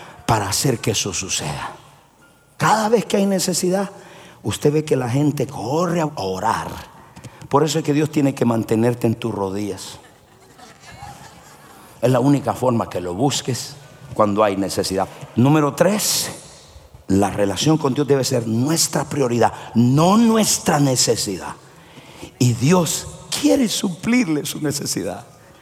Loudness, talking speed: -19 LUFS, 135 wpm